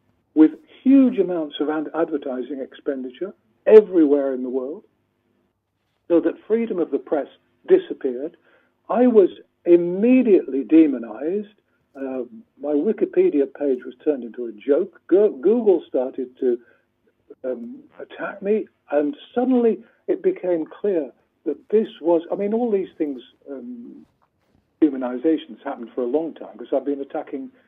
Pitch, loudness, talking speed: 160 Hz, -21 LUFS, 130 wpm